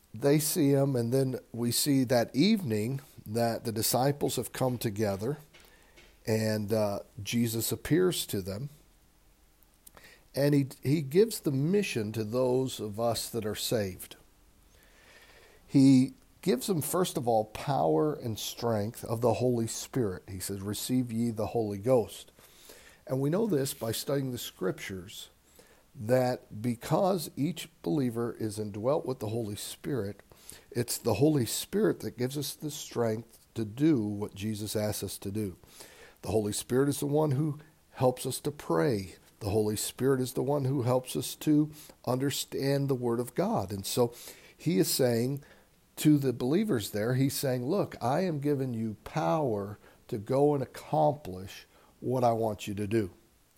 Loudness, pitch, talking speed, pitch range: -30 LUFS, 125 Hz, 160 wpm, 110-145 Hz